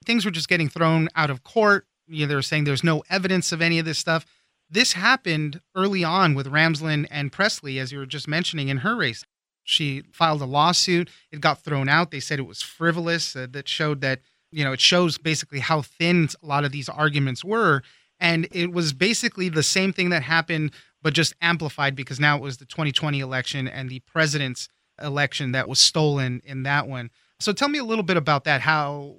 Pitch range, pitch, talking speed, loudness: 140-170 Hz, 155 Hz, 215 wpm, -22 LUFS